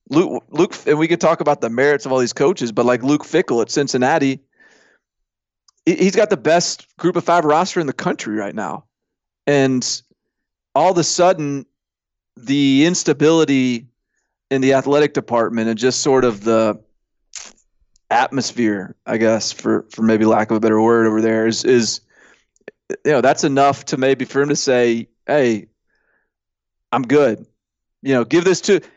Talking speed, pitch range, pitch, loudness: 170 wpm, 115-160 Hz, 135 Hz, -17 LUFS